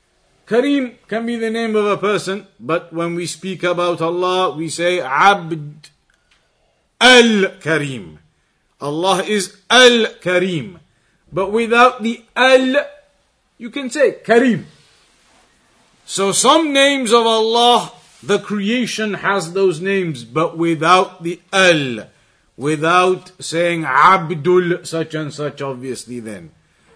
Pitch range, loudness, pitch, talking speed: 160-225 Hz, -15 LUFS, 185 Hz, 115 wpm